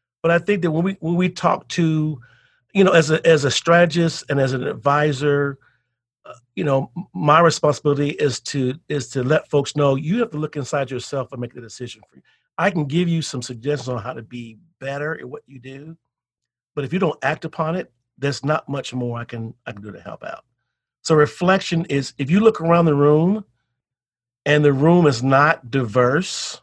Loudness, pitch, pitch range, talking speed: -19 LUFS, 145 Hz, 125-165 Hz, 210 wpm